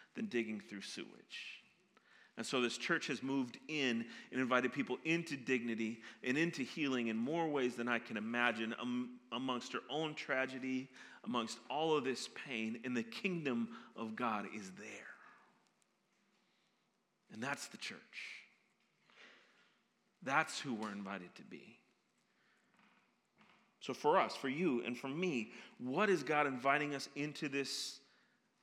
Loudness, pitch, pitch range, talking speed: -39 LUFS, 130 Hz, 120-150 Hz, 145 wpm